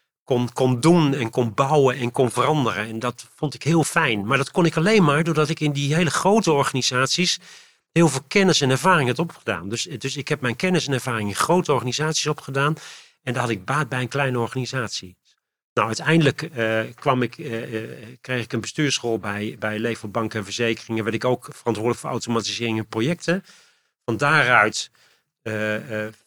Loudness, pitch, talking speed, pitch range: -22 LUFS, 130 Hz, 190 wpm, 115-155 Hz